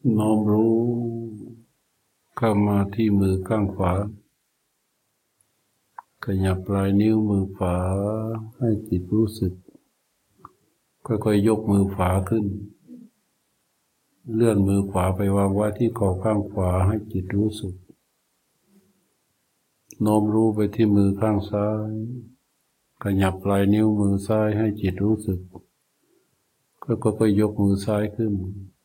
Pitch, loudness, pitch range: 105 Hz, -23 LUFS, 100-110 Hz